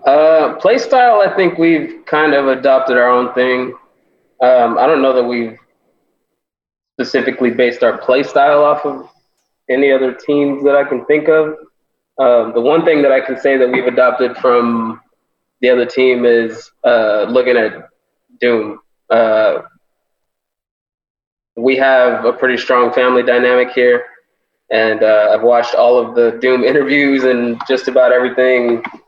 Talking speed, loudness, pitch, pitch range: 155 wpm, -12 LUFS, 125 Hz, 120-140 Hz